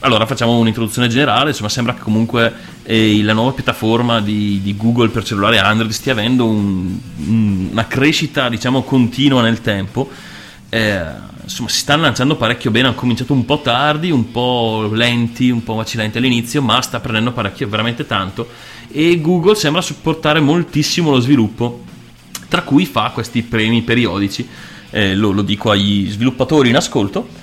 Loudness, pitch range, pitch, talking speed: -15 LUFS, 110-135 Hz, 120 Hz, 160 wpm